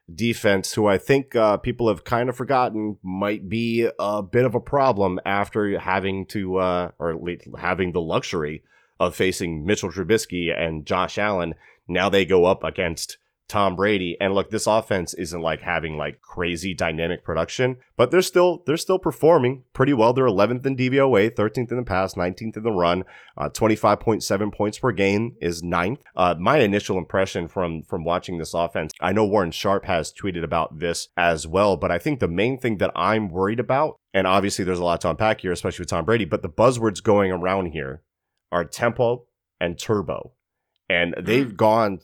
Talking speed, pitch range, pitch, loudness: 190 wpm, 90-115 Hz, 100 Hz, -22 LUFS